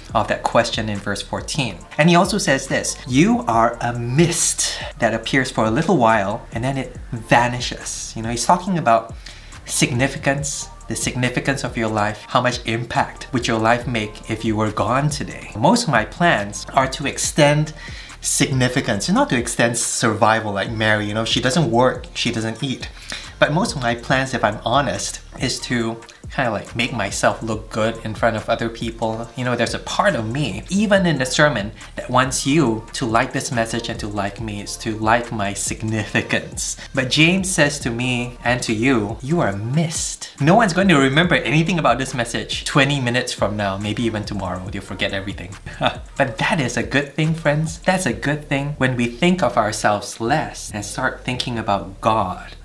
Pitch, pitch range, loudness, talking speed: 120 Hz, 110-140 Hz, -19 LUFS, 195 wpm